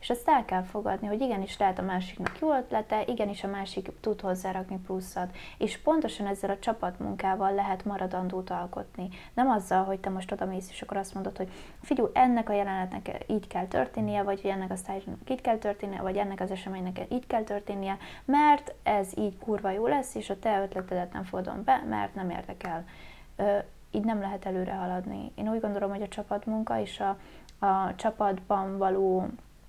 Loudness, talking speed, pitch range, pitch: -30 LUFS, 180 wpm, 190-215 Hz, 195 Hz